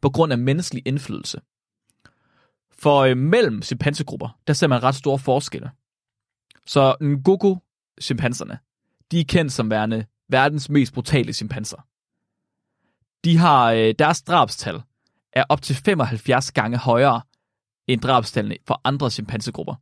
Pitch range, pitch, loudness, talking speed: 115-150 Hz, 135 Hz, -20 LUFS, 125 wpm